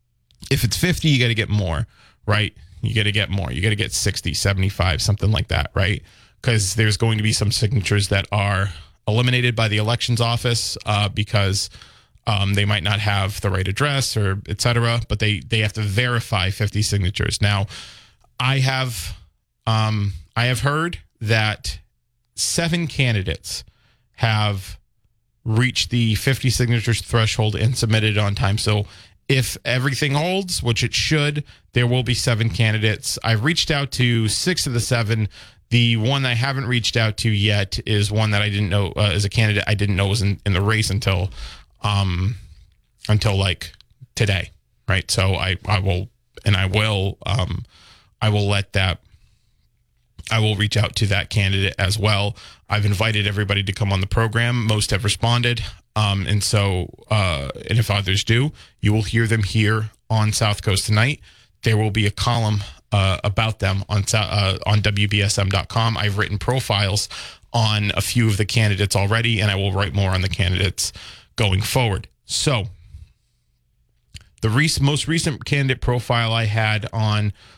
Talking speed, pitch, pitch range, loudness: 170 wpm, 105 Hz, 100-115 Hz, -20 LUFS